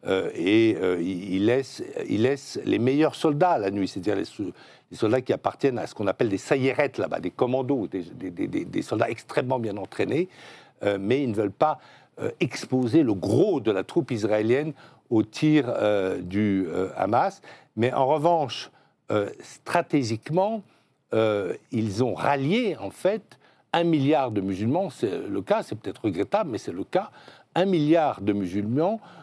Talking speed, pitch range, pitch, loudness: 175 wpm, 110-170 Hz, 140 Hz, -25 LUFS